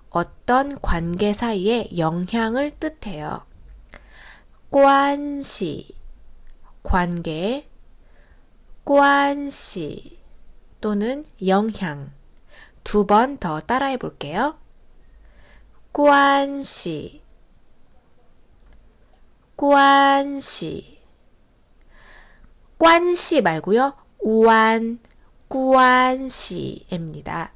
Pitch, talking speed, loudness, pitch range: 255 Hz, 105 characters per minute, -19 LUFS, 205-280 Hz